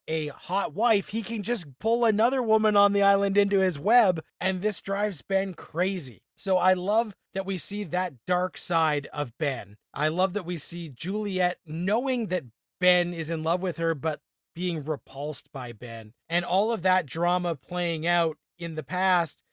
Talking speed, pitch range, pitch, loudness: 185 wpm, 160-200 Hz, 180 Hz, -27 LUFS